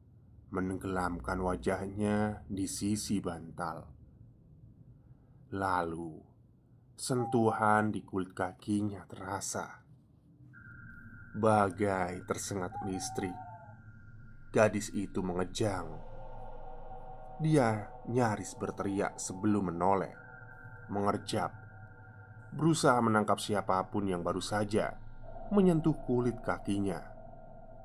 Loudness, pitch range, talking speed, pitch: -33 LUFS, 95-125 Hz, 70 wpm, 105 Hz